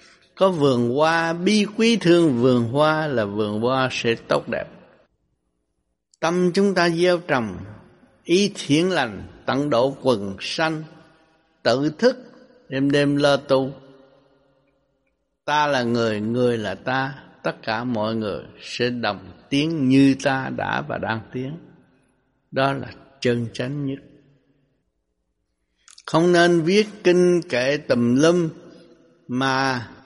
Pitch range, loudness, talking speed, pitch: 120-160 Hz, -21 LUFS, 130 wpm, 135 Hz